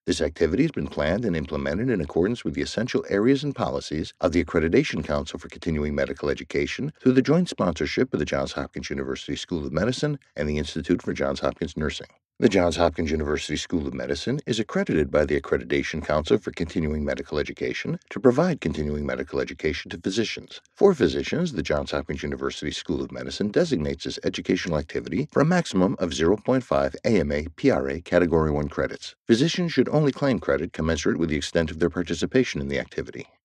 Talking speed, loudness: 185 wpm, -25 LUFS